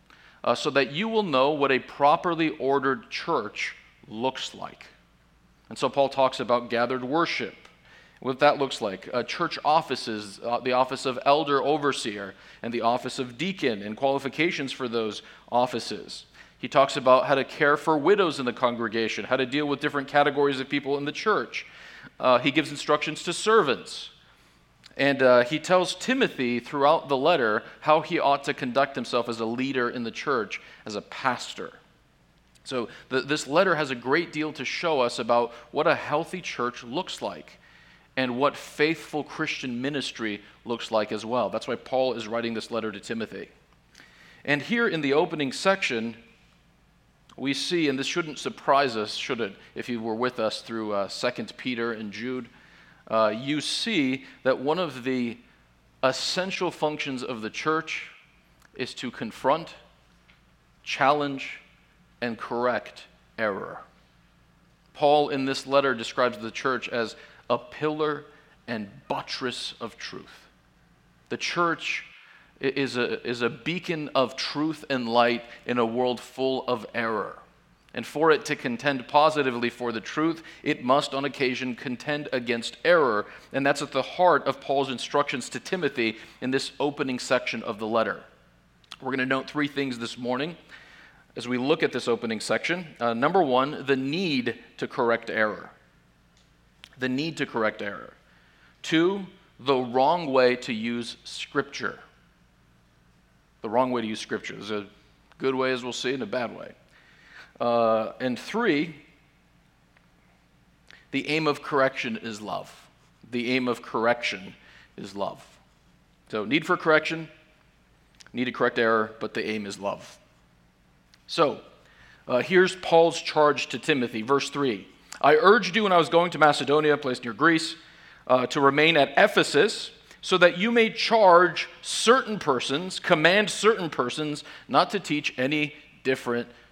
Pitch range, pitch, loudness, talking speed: 120-150 Hz, 135 Hz, -25 LUFS, 160 wpm